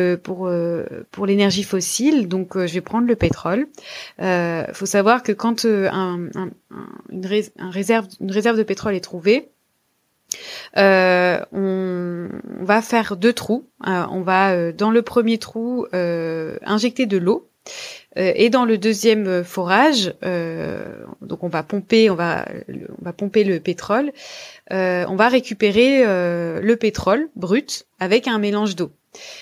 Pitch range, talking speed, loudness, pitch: 185-230 Hz, 155 wpm, -19 LUFS, 200 Hz